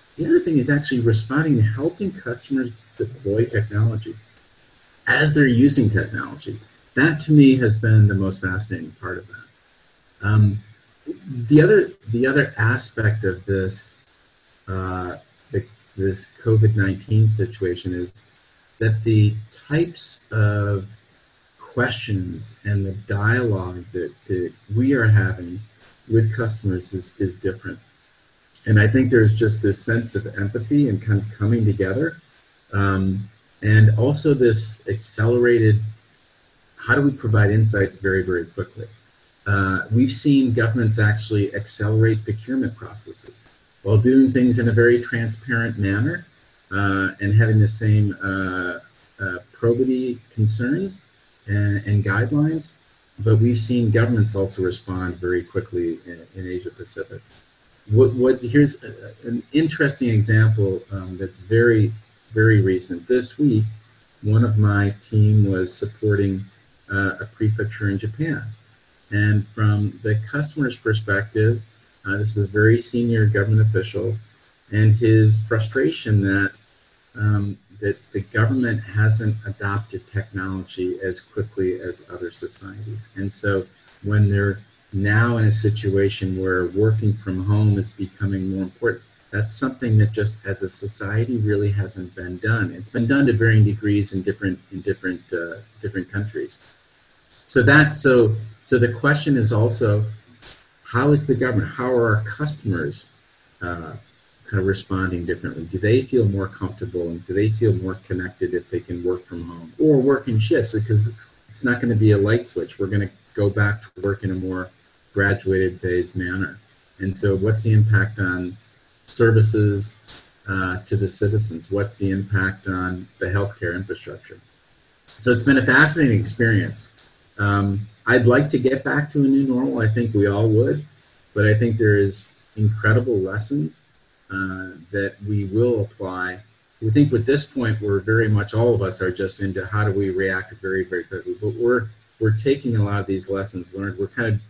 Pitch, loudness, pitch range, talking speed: 110 Hz, -20 LUFS, 100-120 Hz, 150 wpm